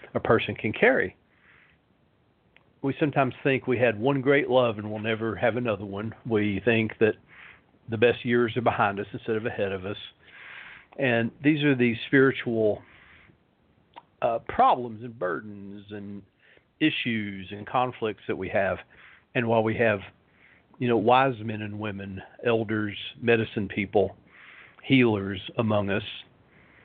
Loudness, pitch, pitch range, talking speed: -26 LUFS, 115 Hz, 105-125 Hz, 145 wpm